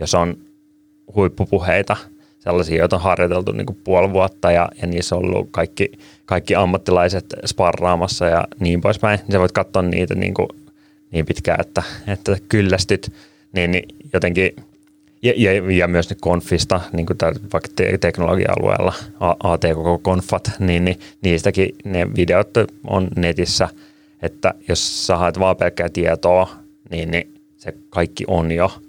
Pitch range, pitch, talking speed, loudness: 85-105 Hz, 95 Hz, 145 wpm, -18 LUFS